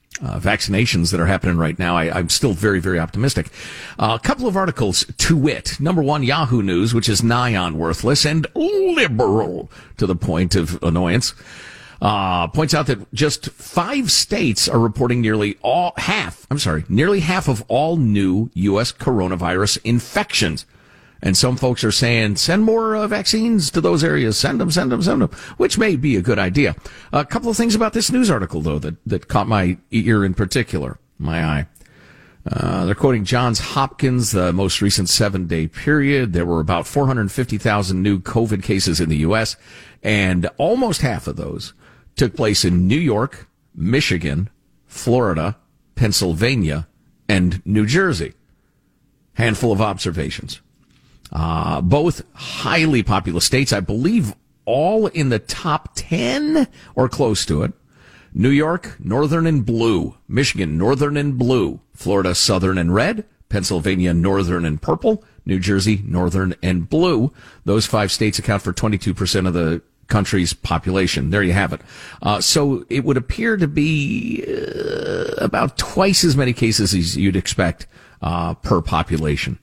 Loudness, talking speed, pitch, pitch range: -18 LUFS, 160 wpm, 110 Hz, 90-140 Hz